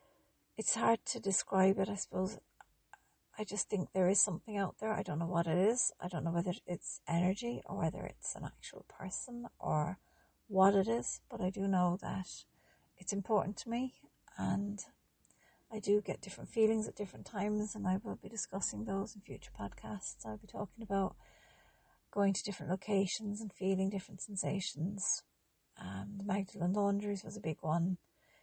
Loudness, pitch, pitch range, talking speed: -37 LUFS, 195 Hz, 185-210 Hz, 175 wpm